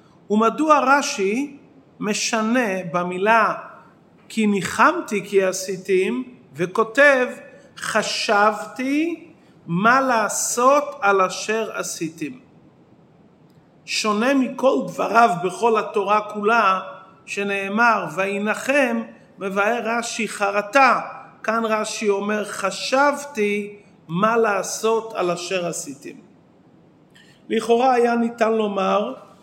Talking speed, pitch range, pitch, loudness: 80 wpm, 195-235 Hz, 215 Hz, -20 LUFS